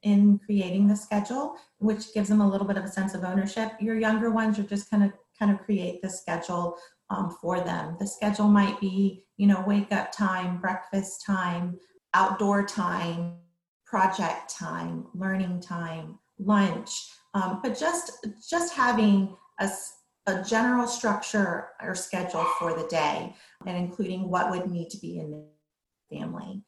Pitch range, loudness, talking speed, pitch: 180-210 Hz, -27 LUFS, 160 wpm, 195 Hz